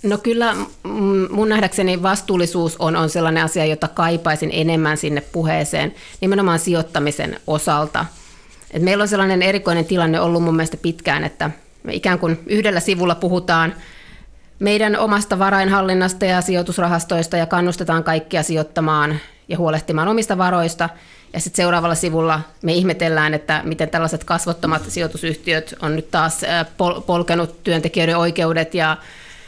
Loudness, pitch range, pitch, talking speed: -18 LUFS, 160-185 Hz, 170 Hz, 130 wpm